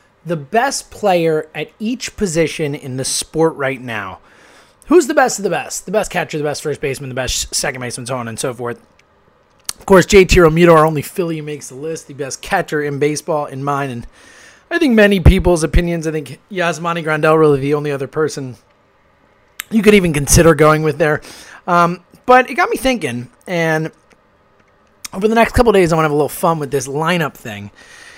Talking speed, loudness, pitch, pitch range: 205 wpm, -15 LUFS, 155 Hz, 140-180 Hz